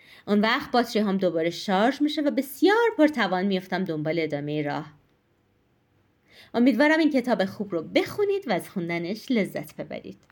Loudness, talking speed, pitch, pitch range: -24 LUFS, 145 wpm, 210 Hz, 180-275 Hz